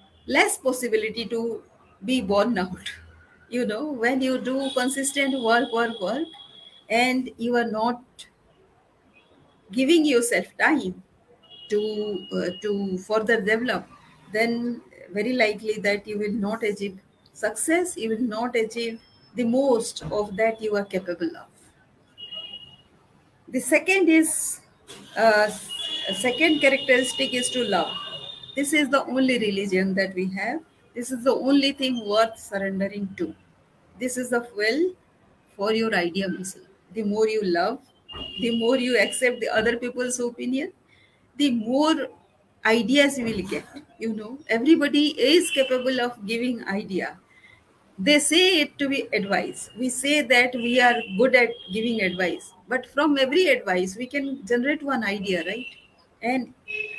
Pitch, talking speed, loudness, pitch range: 235 Hz, 140 wpm, -23 LUFS, 210-265 Hz